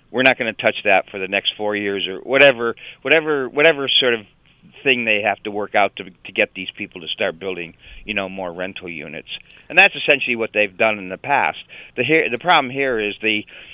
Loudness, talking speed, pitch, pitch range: -18 LUFS, 225 wpm, 110 Hz, 95-140 Hz